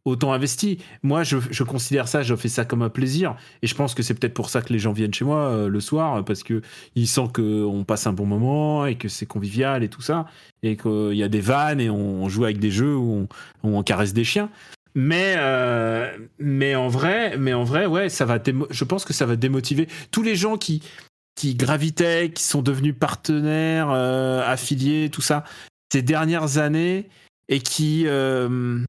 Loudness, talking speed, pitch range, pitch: -22 LUFS, 215 wpm, 115-155 Hz, 135 Hz